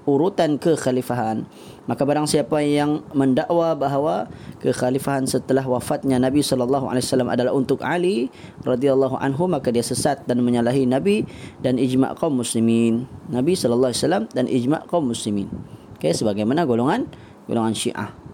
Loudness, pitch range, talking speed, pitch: -21 LUFS, 125-145 Hz, 140 wpm, 130 Hz